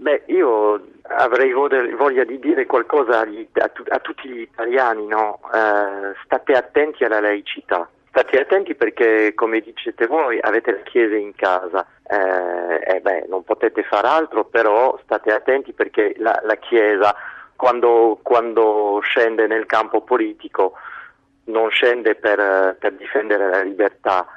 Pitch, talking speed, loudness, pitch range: 110 Hz, 140 wpm, -18 LUFS, 105-155 Hz